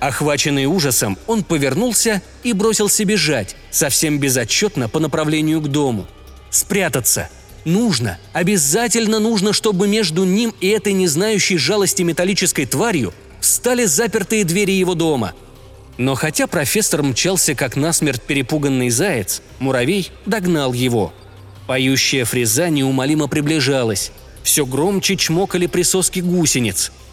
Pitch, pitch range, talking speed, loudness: 160 Hz, 135-195 Hz, 115 wpm, -16 LUFS